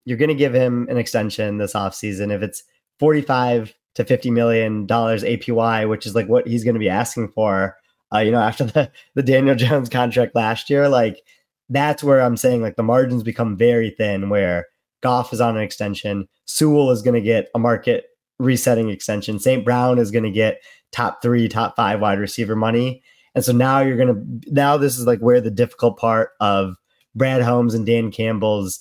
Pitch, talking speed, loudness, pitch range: 120 Hz, 200 wpm, -19 LUFS, 110-125 Hz